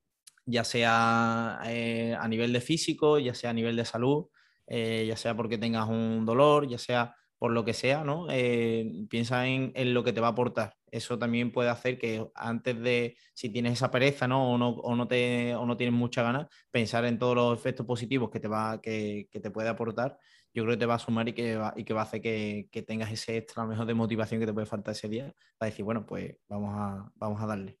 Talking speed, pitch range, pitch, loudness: 235 wpm, 110-120 Hz, 115 Hz, -30 LUFS